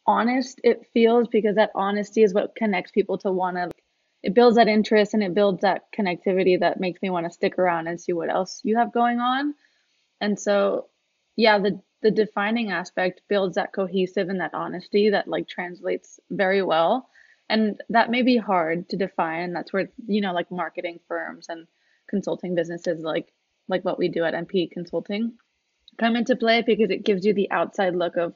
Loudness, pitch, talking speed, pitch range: -23 LUFS, 195 Hz, 195 wpm, 180-220 Hz